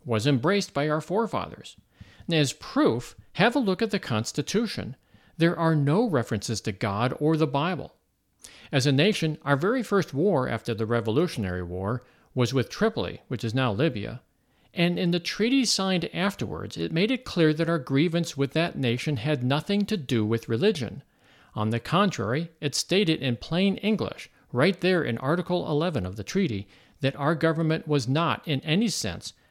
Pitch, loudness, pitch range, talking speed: 150 Hz, -26 LUFS, 120-180 Hz, 175 wpm